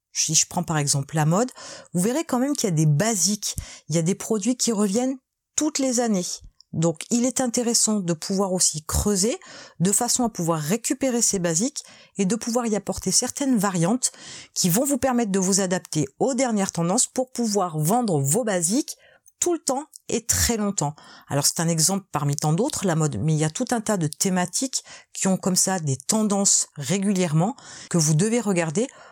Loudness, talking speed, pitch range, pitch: -22 LUFS, 200 wpm, 170-245 Hz, 200 Hz